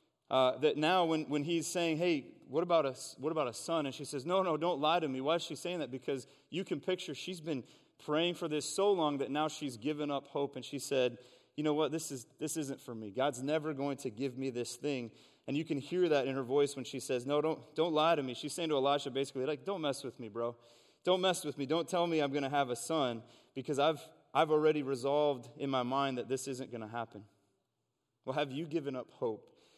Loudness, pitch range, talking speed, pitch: -35 LUFS, 130-160 Hz, 280 wpm, 145 Hz